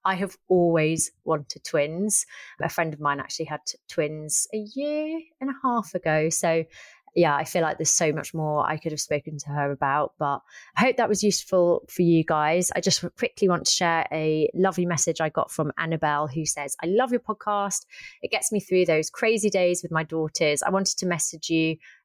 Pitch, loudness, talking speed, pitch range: 165 Hz, -24 LUFS, 210 wpm, 155-195 Hz